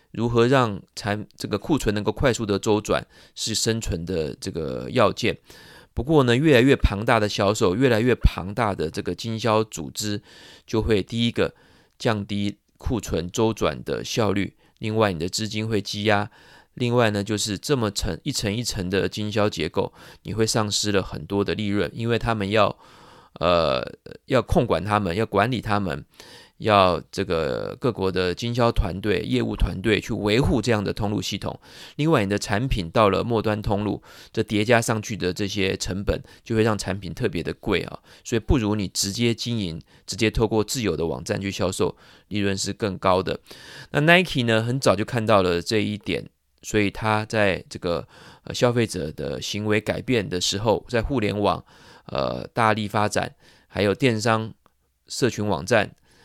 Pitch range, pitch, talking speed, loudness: 100-115 Hz, 105 Hz, 260 characters per minute, -23 LUFS